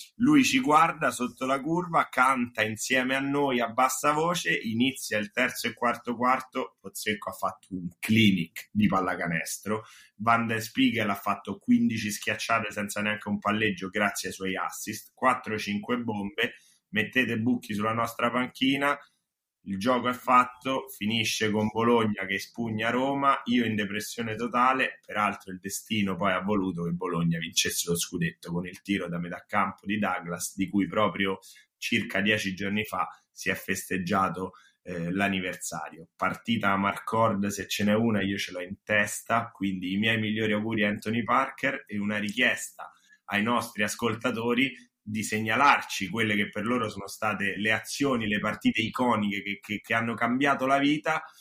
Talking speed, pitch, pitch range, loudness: 160 wpm, 110 Hz, 100-120 Hz, -27 LUFS